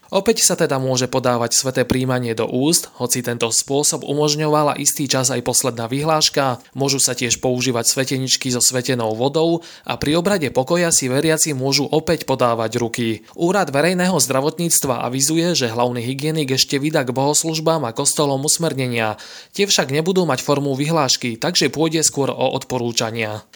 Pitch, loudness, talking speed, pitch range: 135 Hz, -18 LUFS, 155 wpm, 125-155 Hz